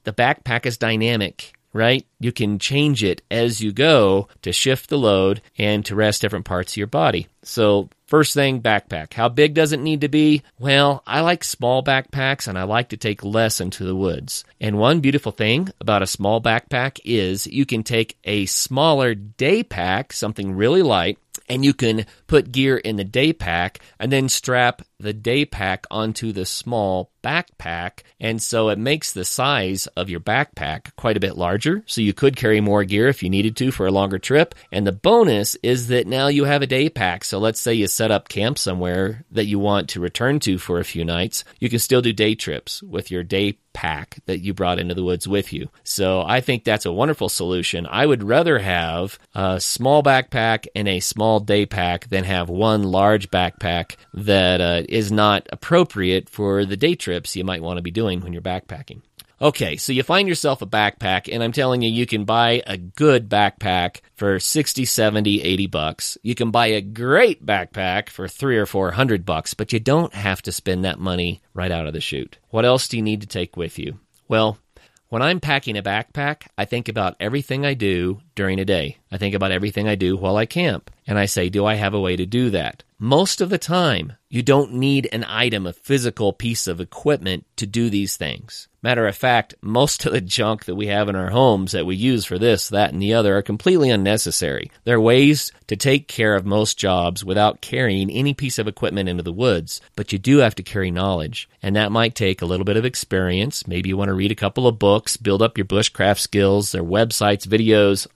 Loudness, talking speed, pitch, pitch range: -20 LUFS, 215 wpm, 105 Hz, 95-125 Hz